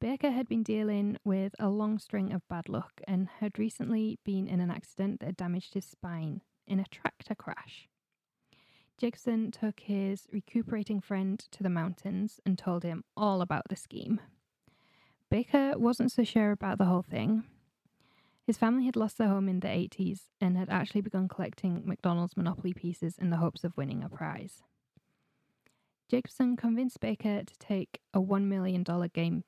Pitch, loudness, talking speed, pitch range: 195 Hz, -33 LUFS, 165 wpm, 185-220 Hz